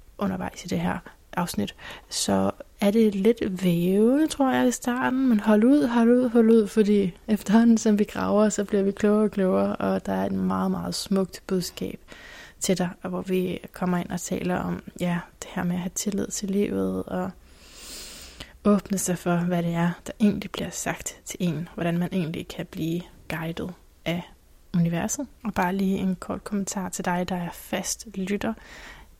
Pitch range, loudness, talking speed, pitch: 175-215 Hz, -25 LUFS, 185 wpm, 190 Hz